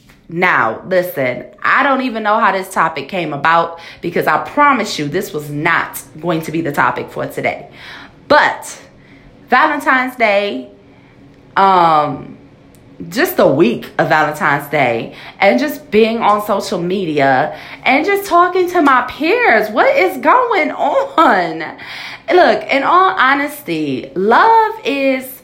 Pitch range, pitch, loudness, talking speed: 165-280 Hz, 205 Hz, -13 LUFS, 135 wpm